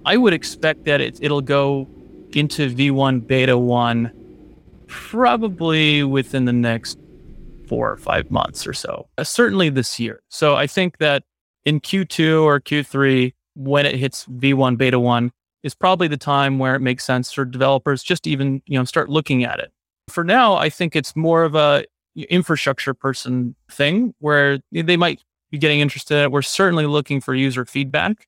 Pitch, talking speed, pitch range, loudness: 145 Hz, 175 wpm, 130-155 Hz, -18 LUFS